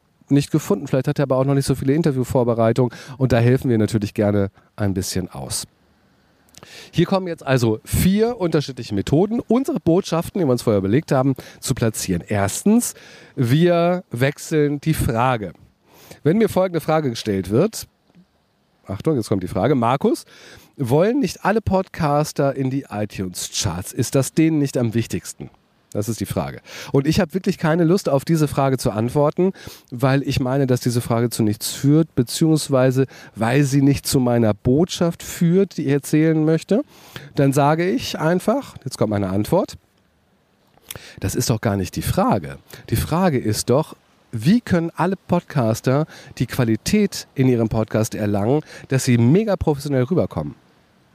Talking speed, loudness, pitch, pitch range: 160 wpm, -20 LUFS, 135 Hz, 115-160 Hz